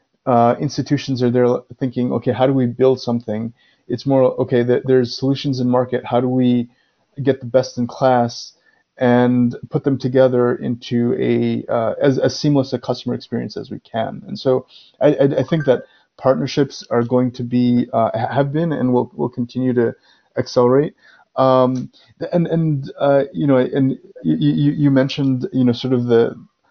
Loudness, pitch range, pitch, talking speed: -18 LUFS, 125-135 Hz, 130 Hz, 175 wpm